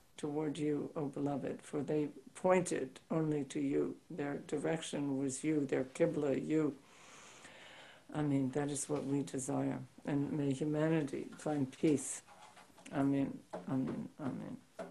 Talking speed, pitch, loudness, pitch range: 140 wpm, 145 Hz, -37 LUFS, 140-155 Hz